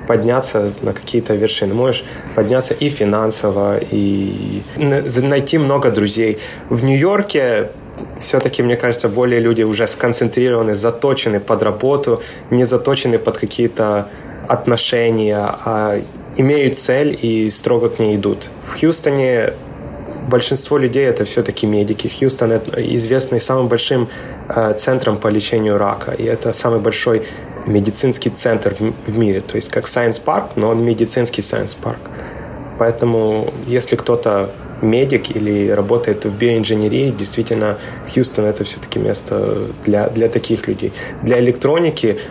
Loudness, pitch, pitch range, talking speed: -16 LUFS, 115 Hz, 105-125 Hz, 130 wpm